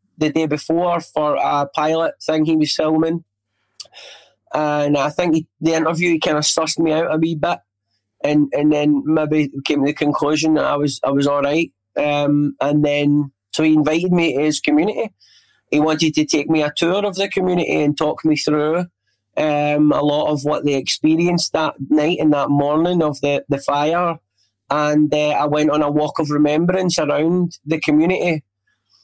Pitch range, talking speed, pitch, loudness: 145-160 Hz, 190 wpm, 150 Hz, -18 LUFS